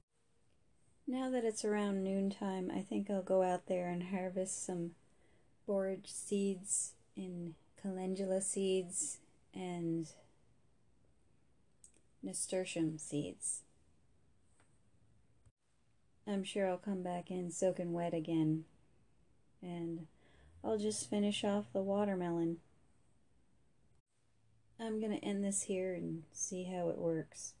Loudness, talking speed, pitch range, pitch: -39 LUFS, 105 wpm, 145-195 Hz, 180 Hz